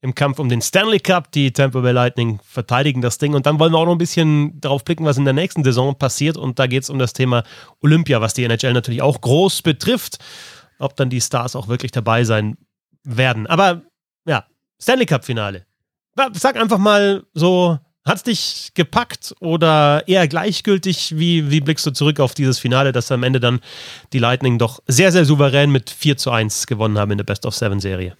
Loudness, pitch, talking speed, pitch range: -17 LUFS, 140 Hz, 205 wpm, 125-165 Hz